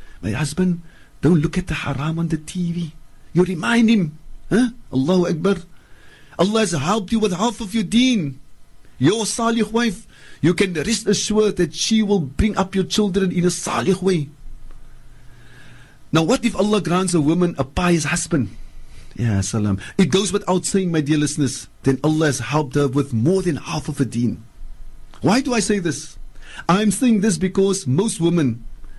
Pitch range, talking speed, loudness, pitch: 140-200 Hz, 175 wpm, -20 LUFS, 170 Hz